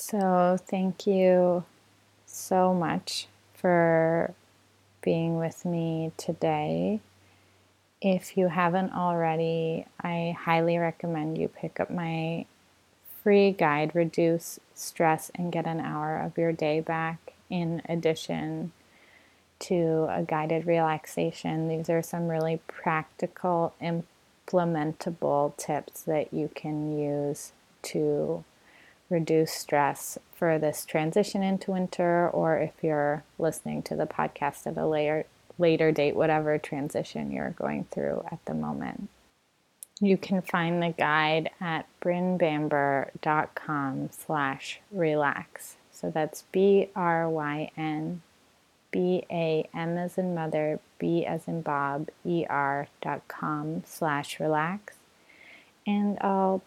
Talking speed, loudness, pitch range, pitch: 110 wpm, -28 LUFS, 150-175 Hz, 160 Hz